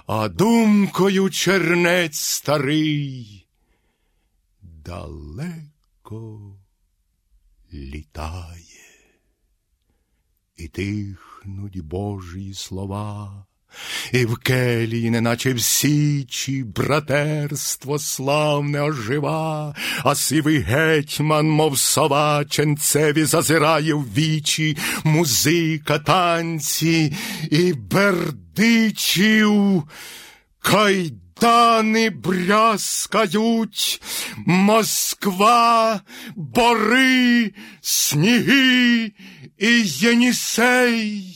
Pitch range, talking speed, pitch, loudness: 125-195 Hz, 55 wpm, 155 Hz, -18 LUFS